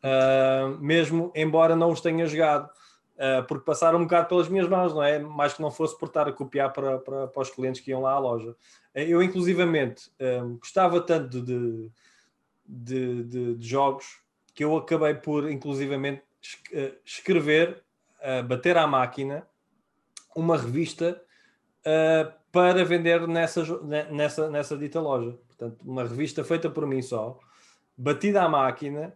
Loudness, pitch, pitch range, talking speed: -25 LUFS, 150 Hz, 135-165 Hz, 155 wpm